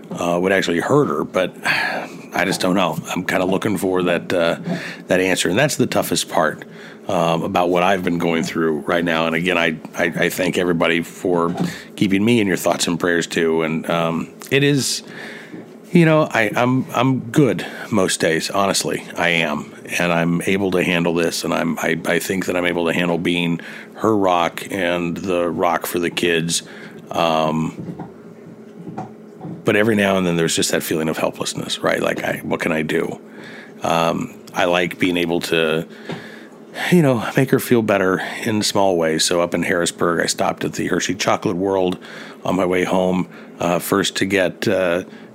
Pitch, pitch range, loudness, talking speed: 90 Hz, 85-105 Hz, -19 LUFS, 190 wpm